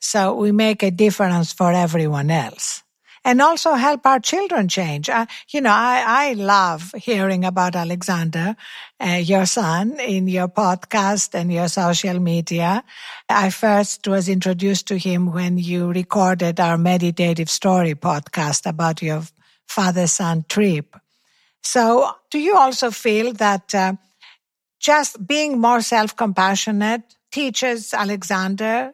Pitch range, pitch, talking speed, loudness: 180-230 Hz, 195 Hz, 135 wpm, -18 LUFS